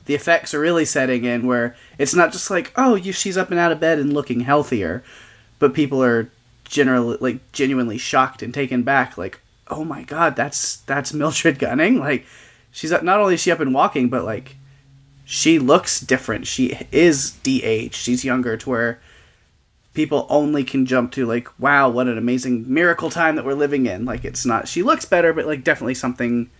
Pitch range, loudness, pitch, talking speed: 125-160 Hz, -19 LUFS, 135 Hz, 195 wpm